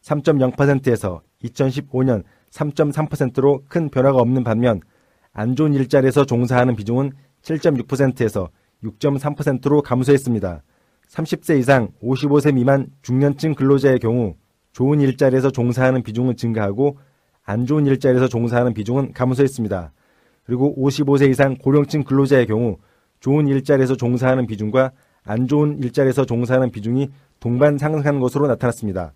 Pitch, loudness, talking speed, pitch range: 130 Hz, -18 LUFS, 305 characters per minute, 120-140 Hz